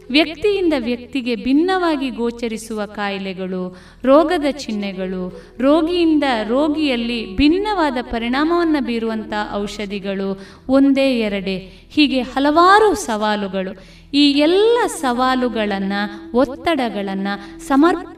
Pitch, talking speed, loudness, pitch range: 250 Hz, 75 wpm, -18 LUFS, 205-300 Hz